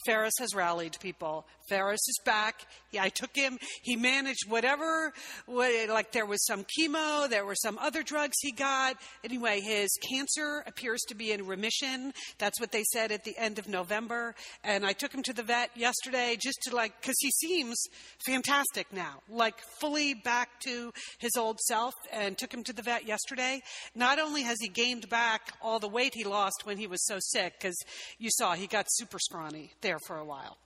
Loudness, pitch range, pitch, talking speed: -31 LUFS, 205-260 Hz, 235 Hz, 195 wpm